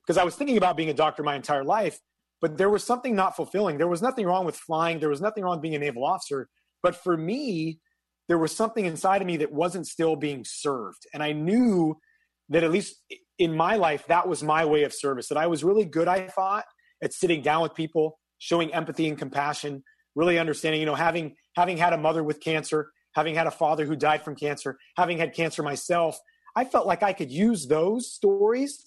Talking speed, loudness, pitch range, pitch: 225 wpm, -26 LUFS, 155-190 Hz, 165 Hz